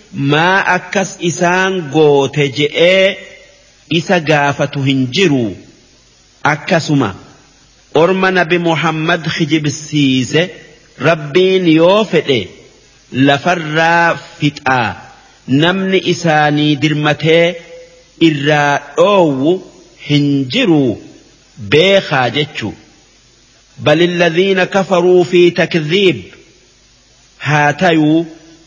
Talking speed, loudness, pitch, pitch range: 65 wpm, -12 LUFS, 165 Hz, 145-175 Hz